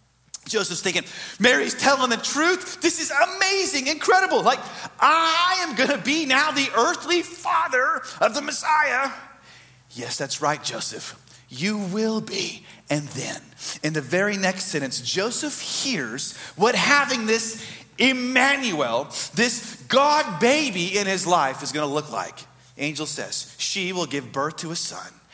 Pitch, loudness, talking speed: 220 Hz, -22 LUFS, 150 wpm